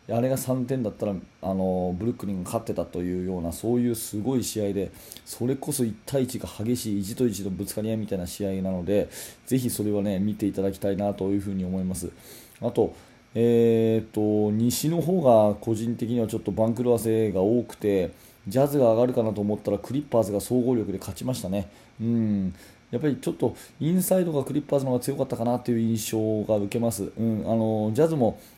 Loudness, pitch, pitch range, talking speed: -26 LUFS, 110 Hz, 100-120 Hz, 415 characters per minute